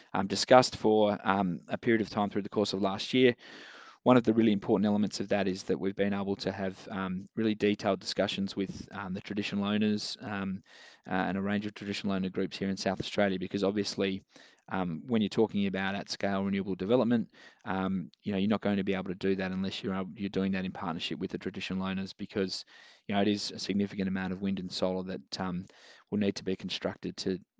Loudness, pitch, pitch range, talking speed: -31 LUFS, 100 Hz, 95-105 Hz, 230 wpm